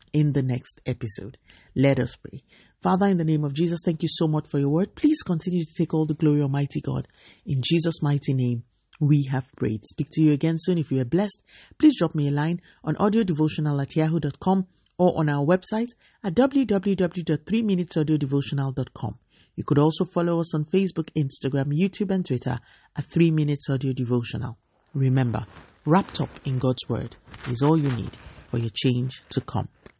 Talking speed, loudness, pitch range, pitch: 185 wpm, -24 LUFS, 130-170 Hz, 150 Hz